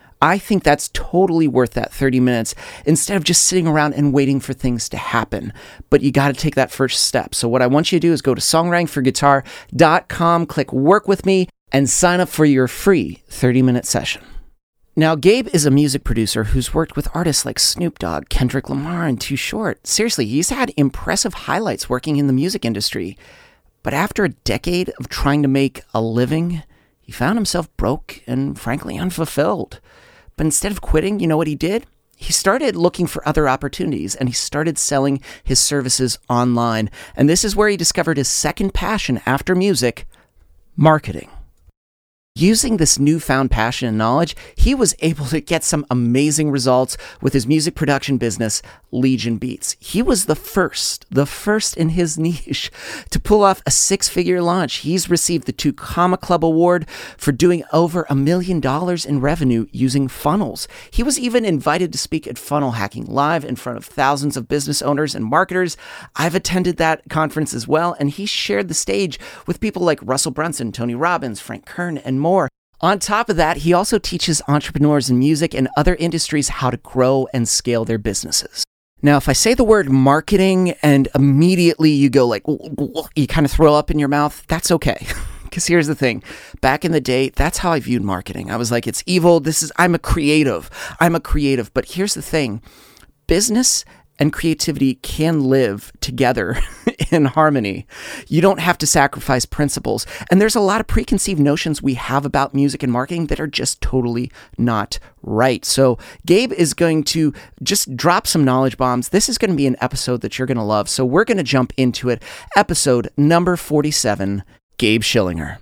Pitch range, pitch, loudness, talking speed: 130-170 Hz, 145 Hz, -17 LUFS, 190 wpm